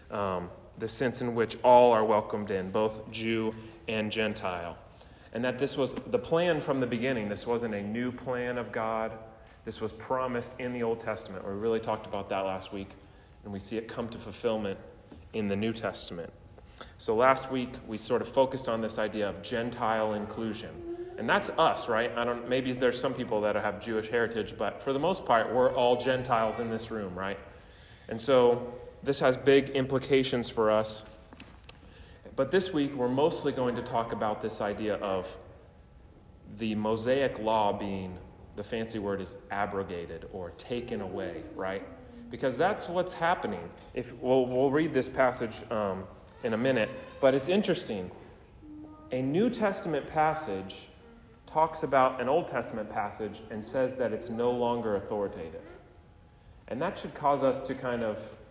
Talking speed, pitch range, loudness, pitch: 170 wpm, 105-130 Hz, -30 LUFS, 115 Hz